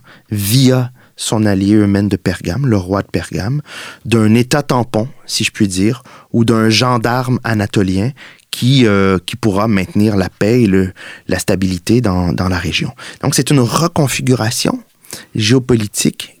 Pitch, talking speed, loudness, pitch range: 110 Hz, 150 wpm, -14 LUFS, 100-125 Hz